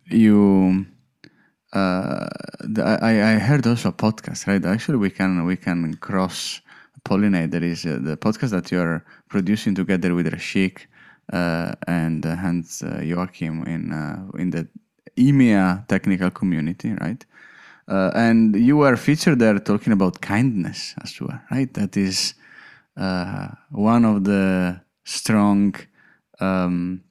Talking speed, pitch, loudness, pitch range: 140 wpm, 95 Hz, -21 LUFS, 90-110 Hz